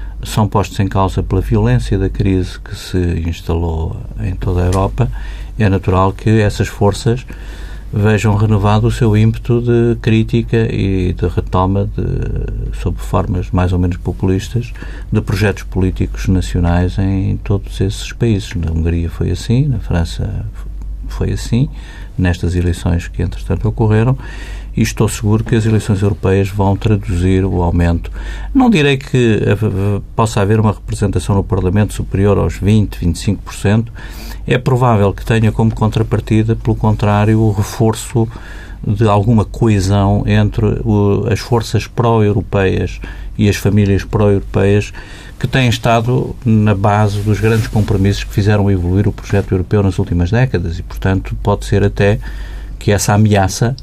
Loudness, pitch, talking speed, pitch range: -15 LUFS, 100 Hz, 145 wpm, 95-110 Hz